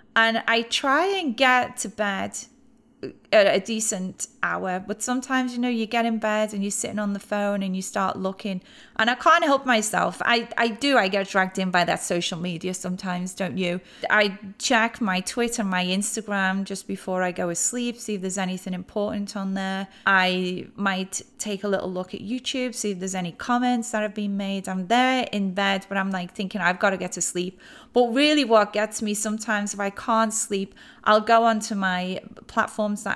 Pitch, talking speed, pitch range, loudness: 205 Hz, 205 wpm, 190-230 Hz, -24 LUFS